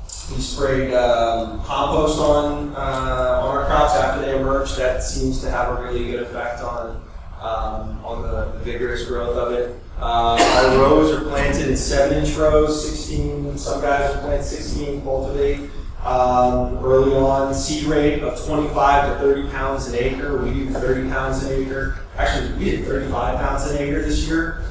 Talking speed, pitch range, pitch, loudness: 170 wpm, 120-140 Hz, 130 Hz, -20 LUFS